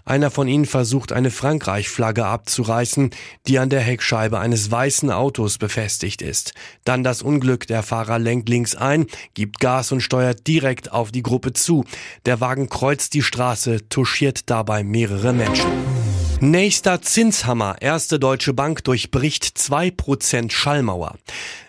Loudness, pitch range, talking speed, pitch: -19 LUFS, 115-140 Hz, 140 wpm, 125 Hz